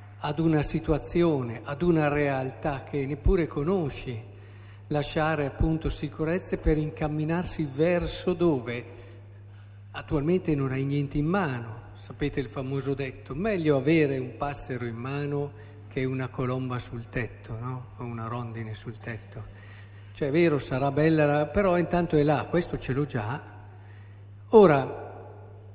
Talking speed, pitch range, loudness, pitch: 135 wpm, 115-155 Hz, -27 LUFS, 135 Hz